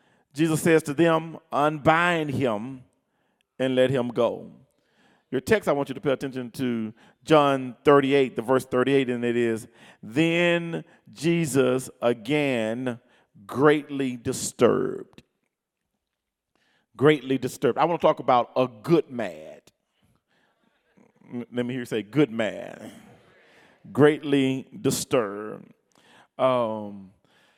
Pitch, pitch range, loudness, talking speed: 130 Hz, 125-150 Hz, -24 LUFS, 115 wpm